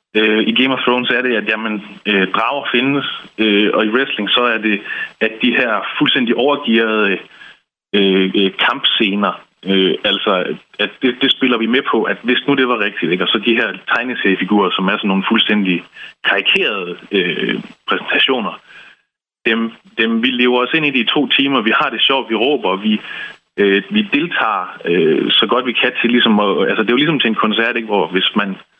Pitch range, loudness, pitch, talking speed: 105-125 Hz, -15 LUFS, 110 Hz, 200 wpm